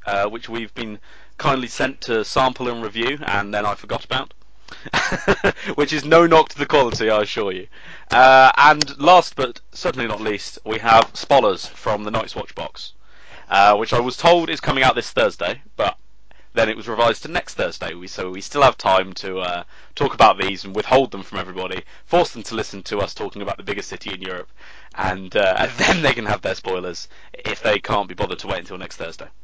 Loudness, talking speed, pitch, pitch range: -19 LUFS, 215 wpm, 110 Hz, 100-130 Hz